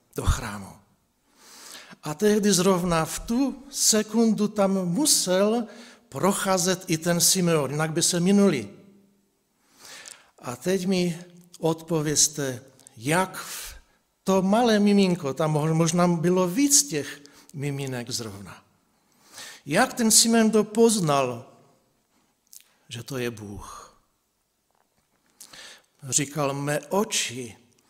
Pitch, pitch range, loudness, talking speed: 175 Hz, 140-205 Hz, -23 LUFS, 100 wpm